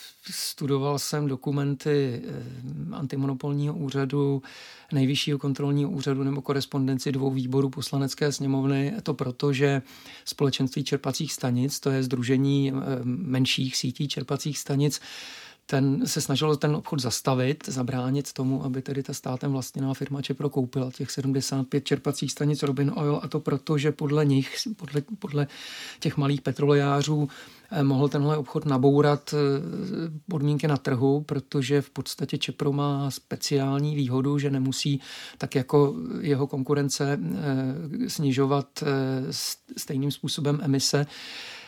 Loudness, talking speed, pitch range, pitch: -26 LUFS, 120 wpm, 135-145 Hz, 140 Hz